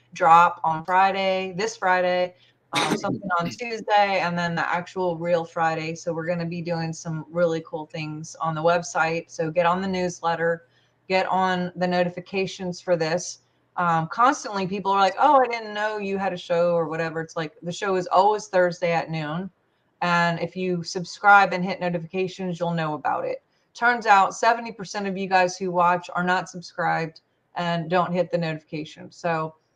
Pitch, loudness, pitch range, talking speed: 175 Hz, -23 LUFS, 165-190 Hz, 180 wpm